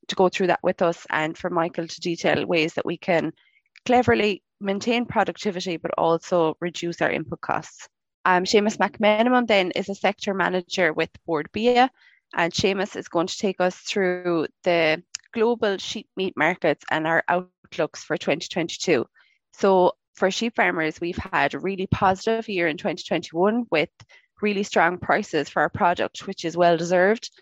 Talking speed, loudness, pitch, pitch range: 165 wpm, -23 LUFS, 185 Hz, 170-210 Hz